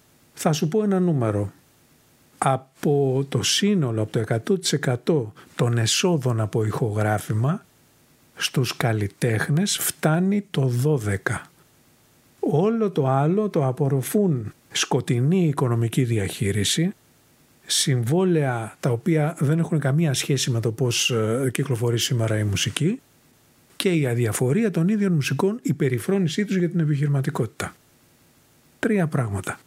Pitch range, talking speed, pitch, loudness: 120-165 Hz, 115 wpm, 140 Hz, -23 LUFS